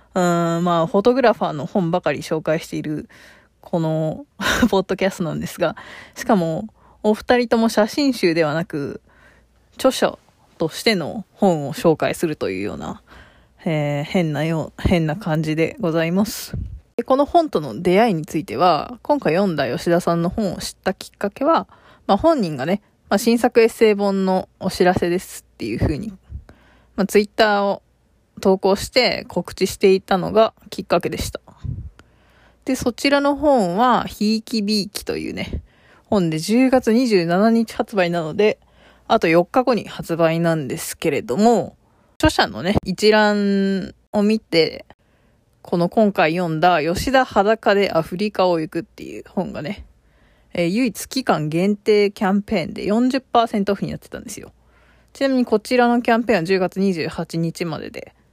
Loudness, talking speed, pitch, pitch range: -19 LUFS, 305 characters per minute, 200 Hz, 170-230 Hz